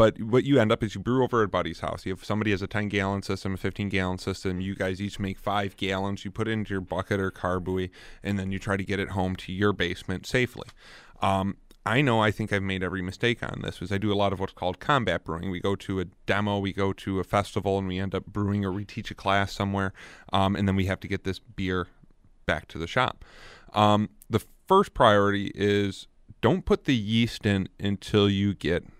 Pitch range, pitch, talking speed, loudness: 95-105 Hz, 100 Hz, 240 wpm, -27 LUFS